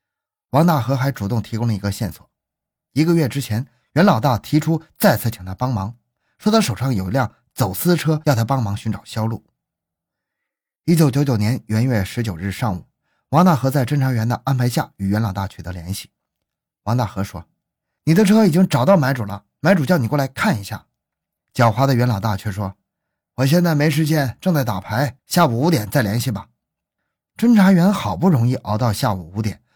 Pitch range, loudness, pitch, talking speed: 105-155 Hz, -19 LUFS, 125 Hz, 280 characters per minute